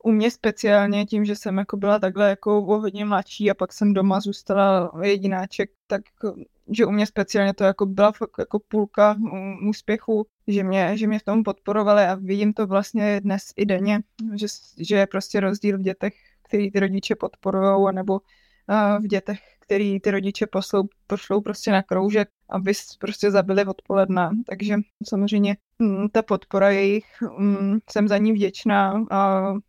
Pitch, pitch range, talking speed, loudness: 200 Hz, 195-210 Hz, 170 wpm, -22 LUFS